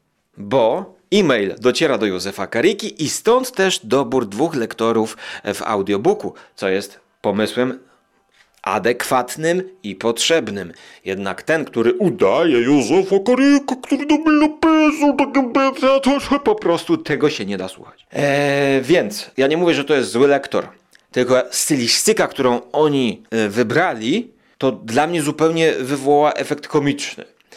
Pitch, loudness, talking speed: 145 Hz, -17 LUFS, 130 wpm